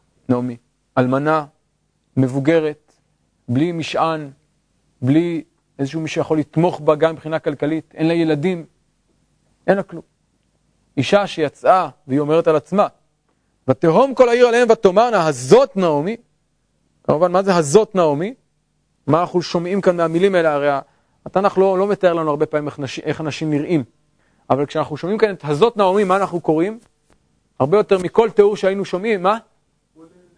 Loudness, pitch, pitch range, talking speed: -17 LUFS, 165 Hz, 150-190 Hz, 145 wpm